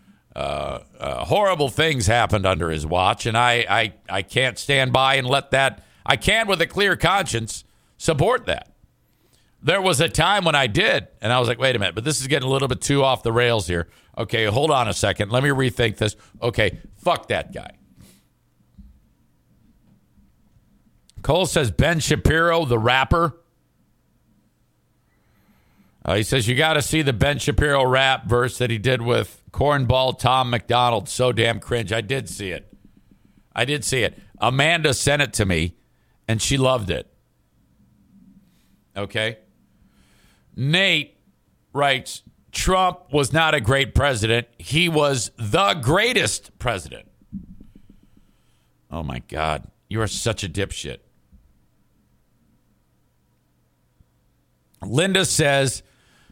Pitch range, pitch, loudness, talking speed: 100-140 Hz, 120 Hz, -20 LUFS, 145 wpm